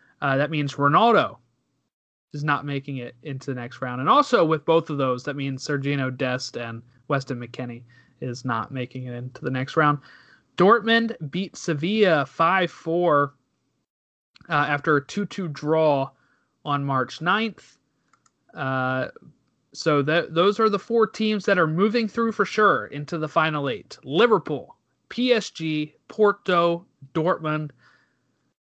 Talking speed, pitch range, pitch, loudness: 145 wpm, 130-175 Hz, 150 Hz, -23 LUFS